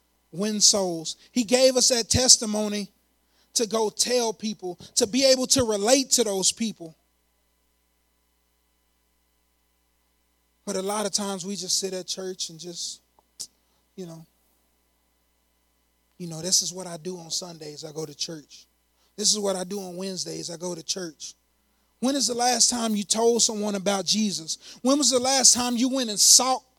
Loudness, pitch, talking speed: -22 LUFS, 185 Hz, 170 wpm